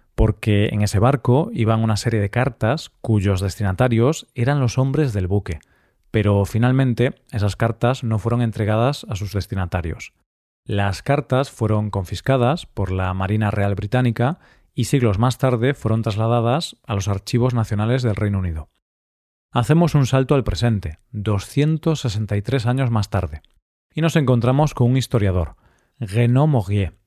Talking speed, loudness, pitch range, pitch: 145 wpm, -20 LUFS, 100-125 Hz, 115 Hz